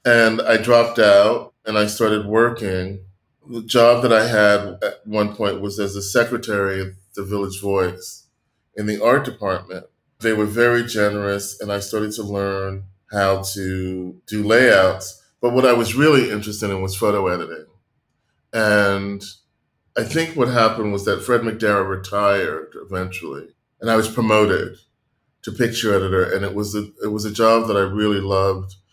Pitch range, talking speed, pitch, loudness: 100-115 Hz, 170 wpm, 105 Hz, -19 LUFS